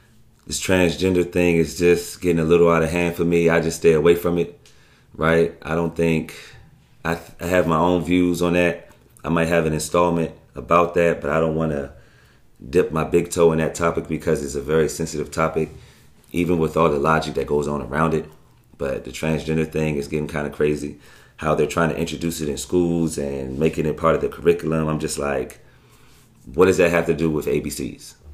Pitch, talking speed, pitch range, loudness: 80 Hz, 215 wpm, 75-85 Hz, -21 LUFS